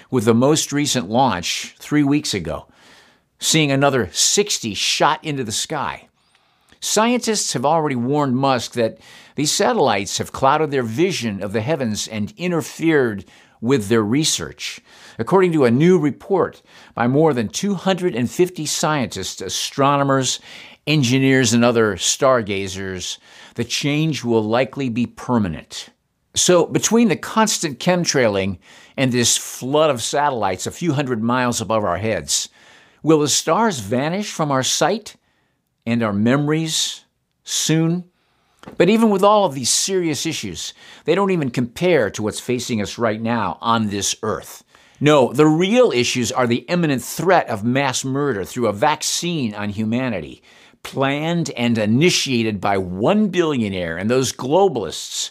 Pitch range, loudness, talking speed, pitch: 115-160 Hz, -18 LUFS, 140 wpm, 130 Hz